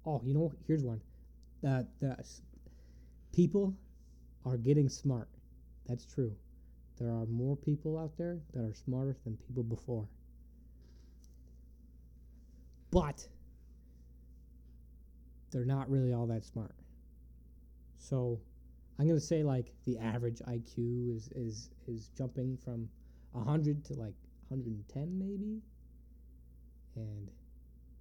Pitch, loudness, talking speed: 110 Hz, -37 LUFS, 115 wpm